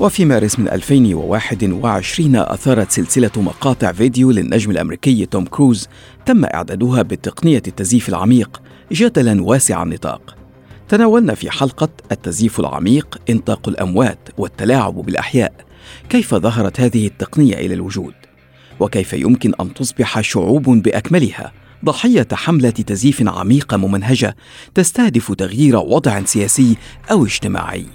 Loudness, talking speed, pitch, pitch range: -15 LUFS, 110 wpm, 115 Hz, 100-135 Hz